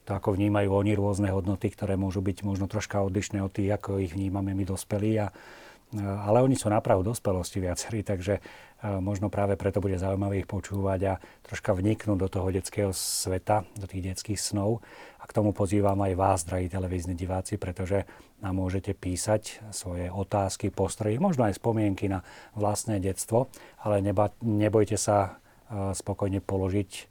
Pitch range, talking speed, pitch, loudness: 95-105 Hz, 160 wpm, 100 Hz, -29 LUFS